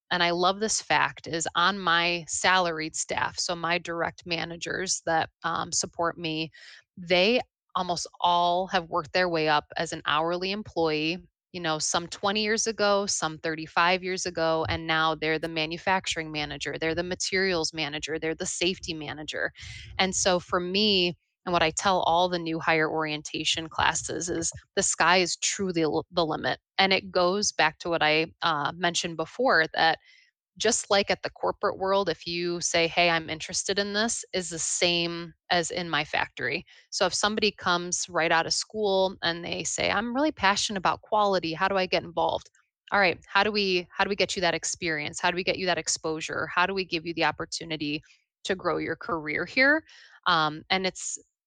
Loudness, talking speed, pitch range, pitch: -26 LUFS, 190 wpm, 160-185 Hz, 175 Hz